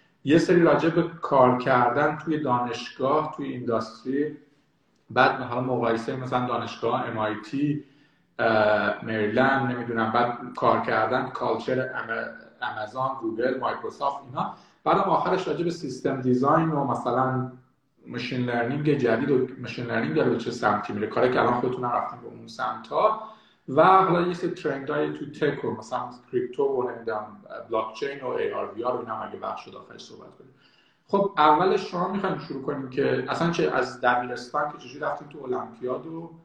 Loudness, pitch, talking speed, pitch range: -25 LUFS, 130 Hz, 155 wpm, 120-155 Hz